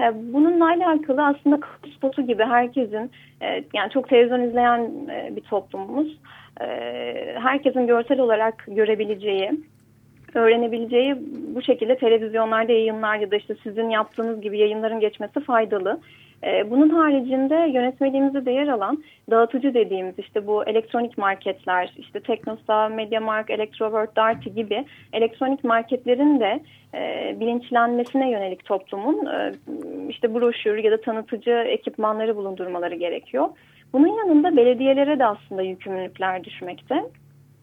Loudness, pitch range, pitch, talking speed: -22 LUFS, 215-265 Hz, 230 Hz, 110 wpm